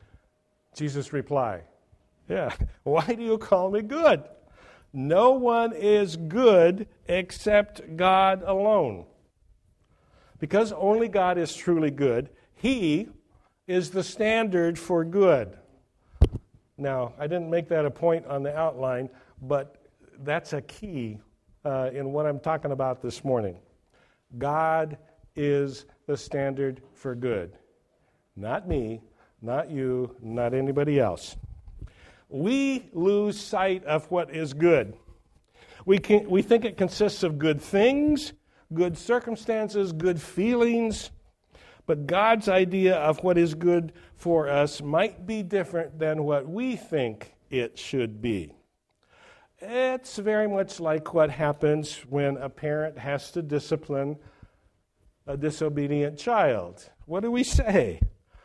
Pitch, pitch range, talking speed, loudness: 155 Hz, 135-195 Hz, 125 wpm, -26 LUFS